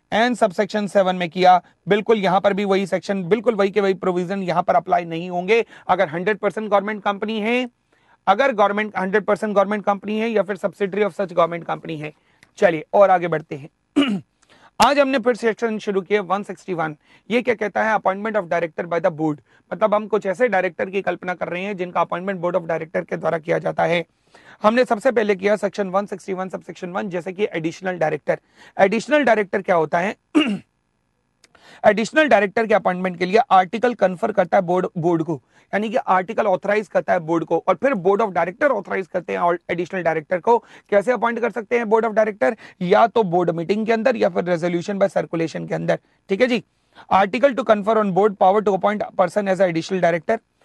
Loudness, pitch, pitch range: -20 LUFS, 200 Hz, 180-215 Hz